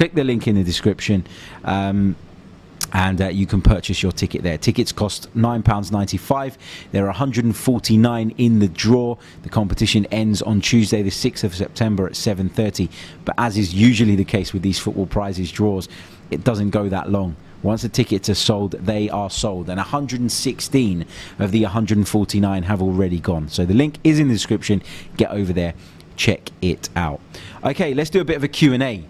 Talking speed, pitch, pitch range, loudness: 180 wpm, 105 Hz, 95-115 Hz, -19 LUFS